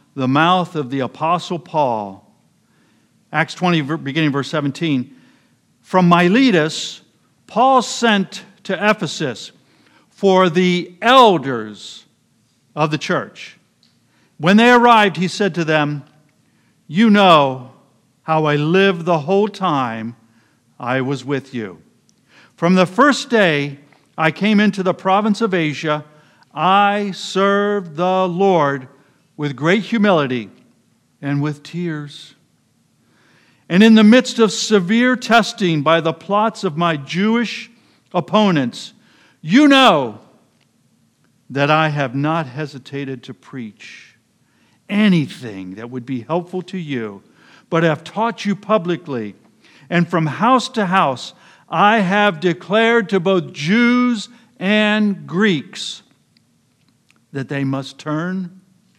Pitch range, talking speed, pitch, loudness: 145-205 Hz, 115 wpm, 175 Hz, -16 LUFS